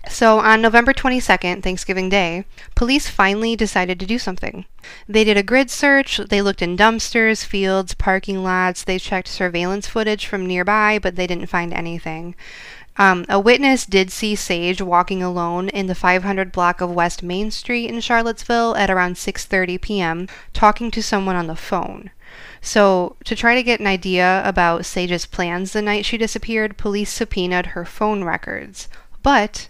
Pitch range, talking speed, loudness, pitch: 180-220 Hz, 170 wpm, -18 LUFS, 195 Hz